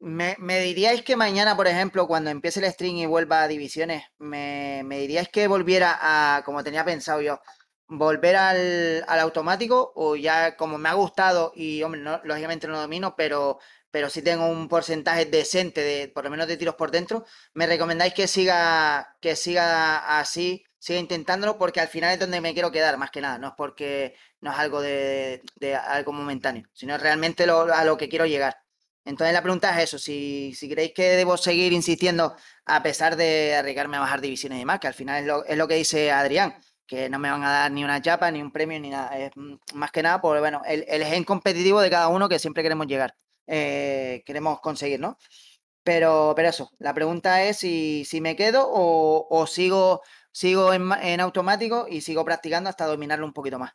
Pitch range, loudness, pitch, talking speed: 145-175 Hz, -23 LUFS, 160 Hz, 205 wpm